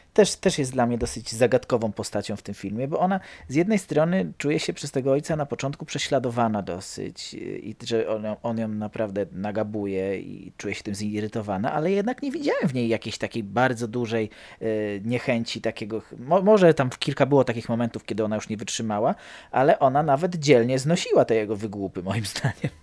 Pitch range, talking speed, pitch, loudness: 110-145 Hz, 195 wpm, 115 Hz, -25 LUFS